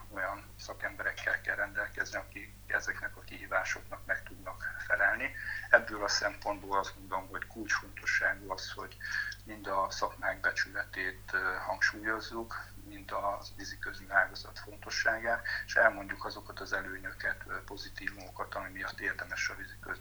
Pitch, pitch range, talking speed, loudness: 100 Hz, 100-110 Hz, 125 wpm, -34 LUFS